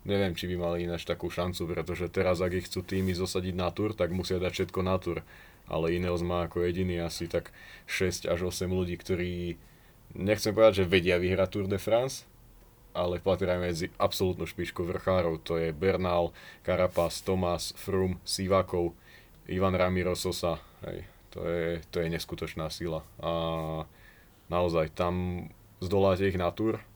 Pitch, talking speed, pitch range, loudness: 90 Hz, 160 wpm, 85-95 Hz, -30 LUFS